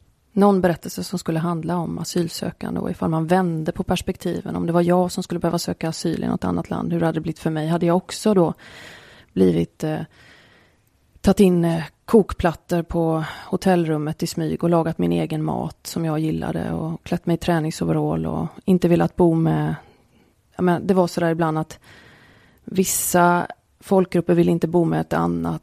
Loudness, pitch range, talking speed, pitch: -21 LUFS, 155-175 Hz, 185 wpm, 170 Hz